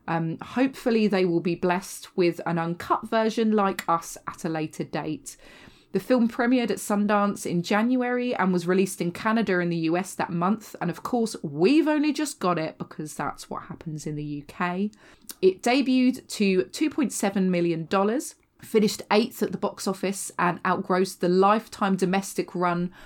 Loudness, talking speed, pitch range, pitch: -25 LUFS, 170 wpm, 175-220 Hz, 190 Hz